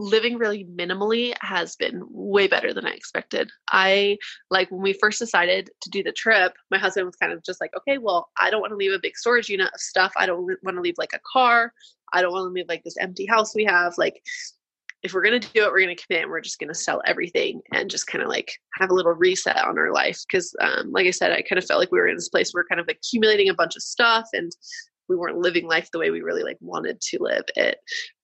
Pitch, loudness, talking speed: 210 Hz, -22 LUFS, 265 wpm